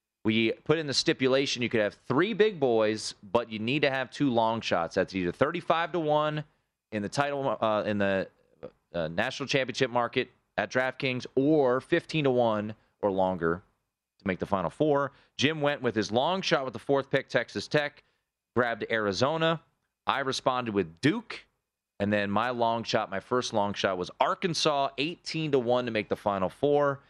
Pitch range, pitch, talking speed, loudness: 105-145 Hz, 125 Hz, 185 wpm, -28 LUFS